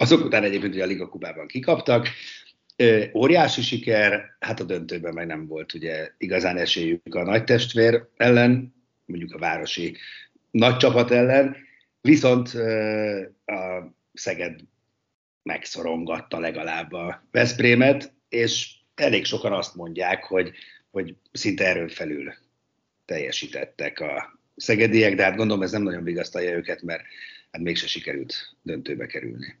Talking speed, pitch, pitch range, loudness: 130 wpm, 105 Hz, 90-120 Hz, -23 LUFS